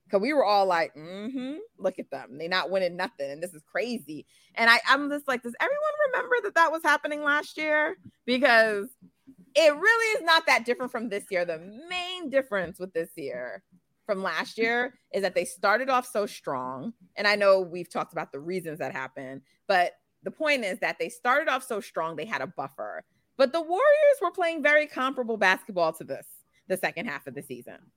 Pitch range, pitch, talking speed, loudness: 180-295 Hz, 230 Hz, 210 wpm, -26 LUFS